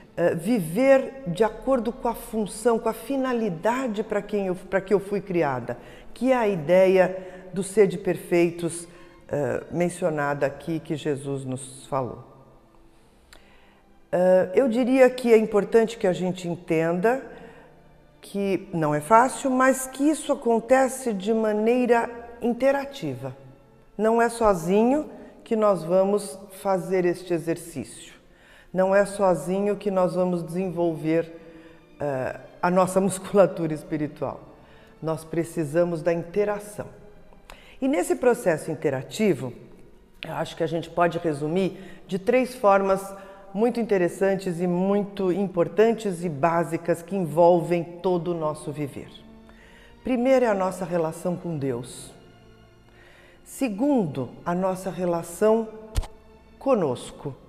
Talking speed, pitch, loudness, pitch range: 120 wpm, 185 Hz, -24 LUFS, 165-220 Hz